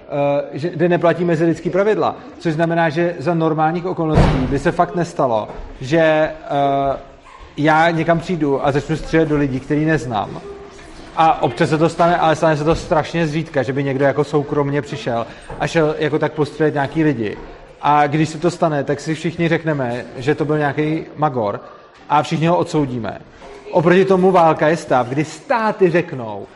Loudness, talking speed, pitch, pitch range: -17 LUFS, 175 wpm, 155 Hz, 145-170 Hz